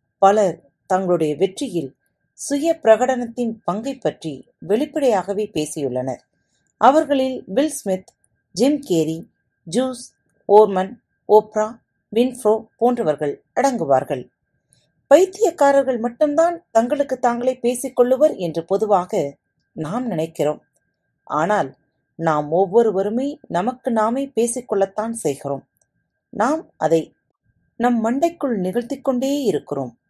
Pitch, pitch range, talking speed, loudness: 220 Hz, 170-260 Hz, 85 wpm, -20 LUFS